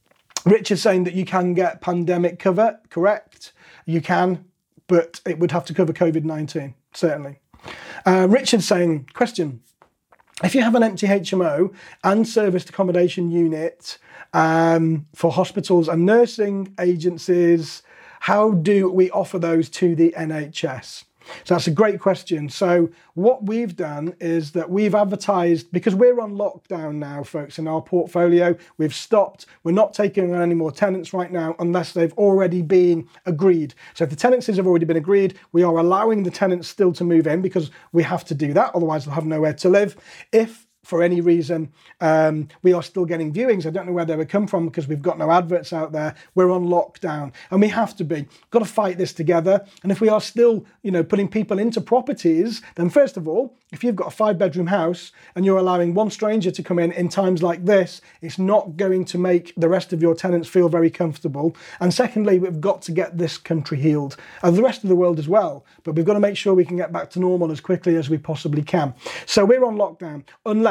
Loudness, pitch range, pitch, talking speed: -20 LUFS, 165-195 Hz, 180 Hz, 210 wpm